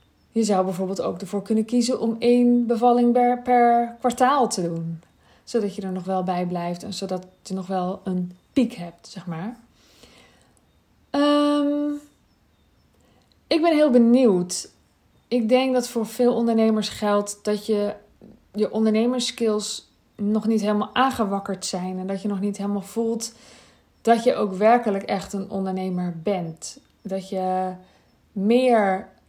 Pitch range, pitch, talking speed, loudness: 190-240 Hz, 210 Hz, 145 wpm, -22 LUFS